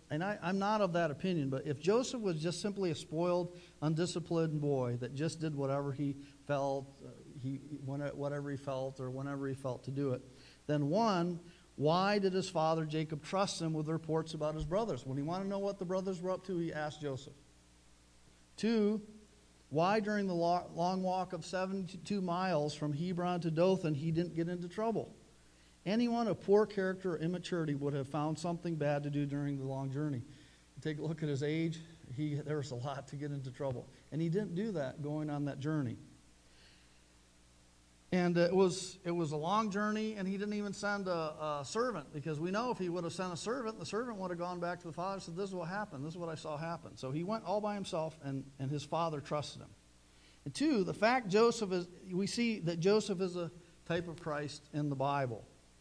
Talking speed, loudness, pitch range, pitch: 215 wpm, -36 LUFS, 140-185 Hz, 160 Hz